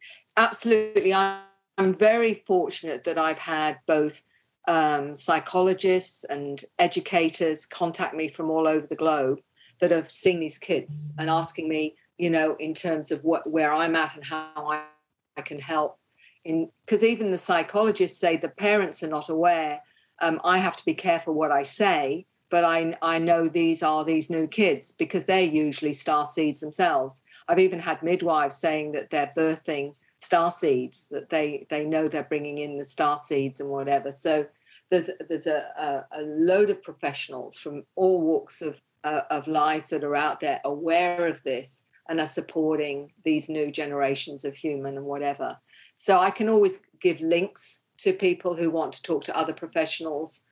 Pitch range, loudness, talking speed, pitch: 150-175 Hz, -25 LUFS, 175 wpm, 160 Hz